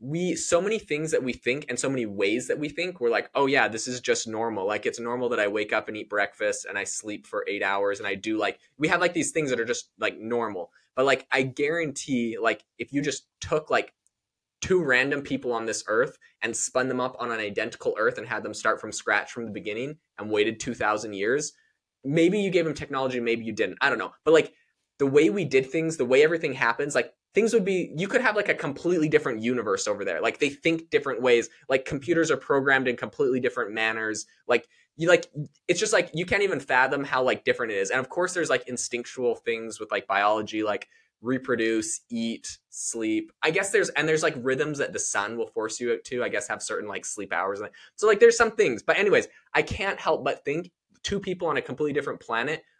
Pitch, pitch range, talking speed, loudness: 145 Hz, 120-180 Hz, 235 wpm, -26 LUFS